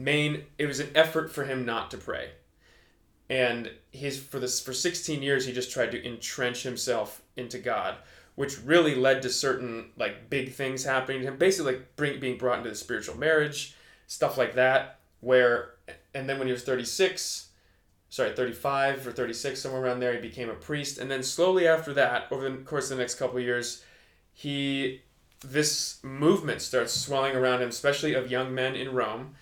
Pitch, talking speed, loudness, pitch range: 130 Hz, 190 wpm, -28 LUFS, 125-140 Hz